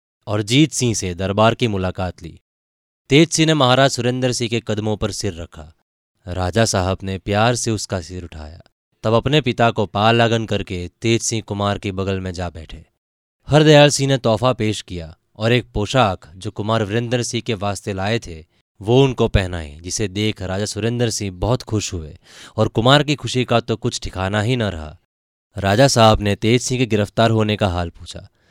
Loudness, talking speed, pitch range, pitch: -18 LUFS, 195 wpm, 95-120 Hz, 105 Hz